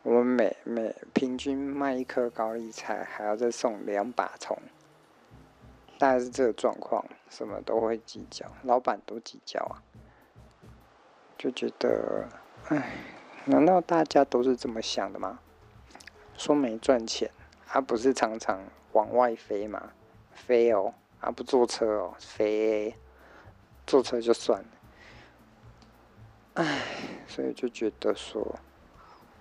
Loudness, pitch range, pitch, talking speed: -29 LUFS, 110-130 Hz, 120 Hz, 180 characters per minute